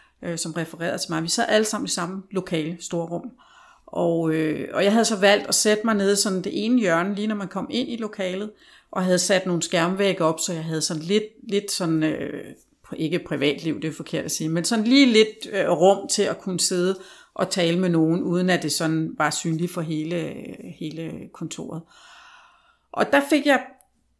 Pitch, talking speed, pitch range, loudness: 185 Hz, 210 wpm, 165-215 Hz, -22 LUFS